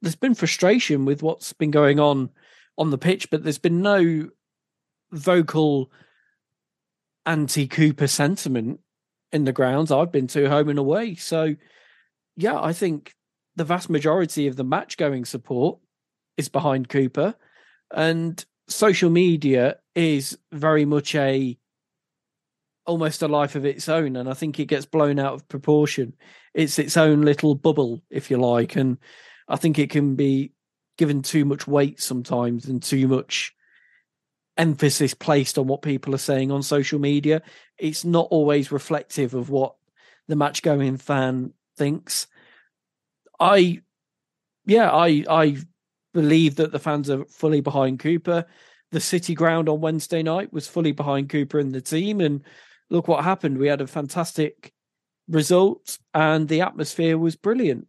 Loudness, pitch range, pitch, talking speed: -22 LUFS, 140-165 Hz, 150 Hz, 150 wpm